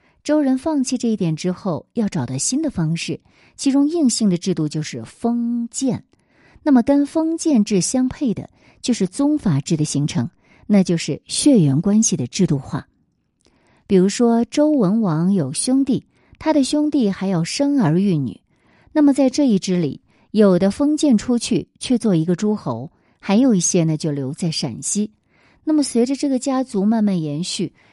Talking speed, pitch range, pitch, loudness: 245 characters per minute, 170-265 Hz, 210 Hz, -19 LUFS